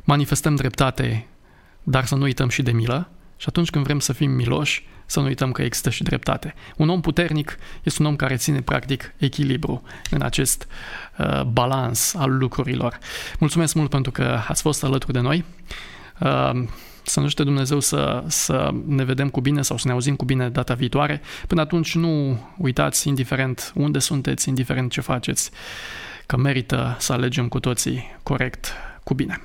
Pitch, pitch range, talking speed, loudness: 135 Hz, 130-145 Hz, 175 wpm, -22 LUFS